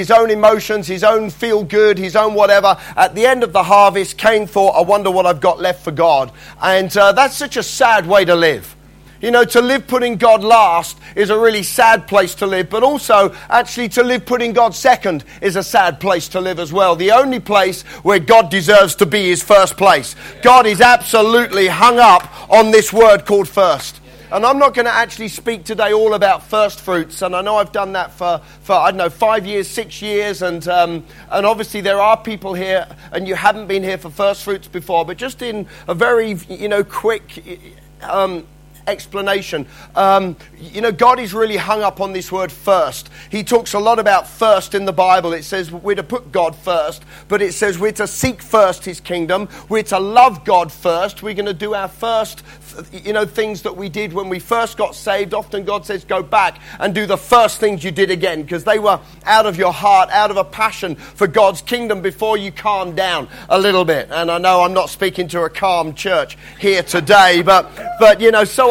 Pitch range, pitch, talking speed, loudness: 185-220 Hz, 200 Hz, 220 wpm, -14 LUFS